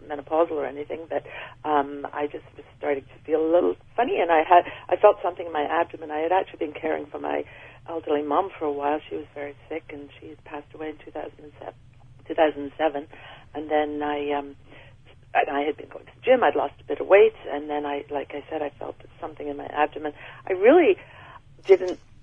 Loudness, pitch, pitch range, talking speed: -24 LUFS, 150 Hz, 140-160 Hz, 210 wpm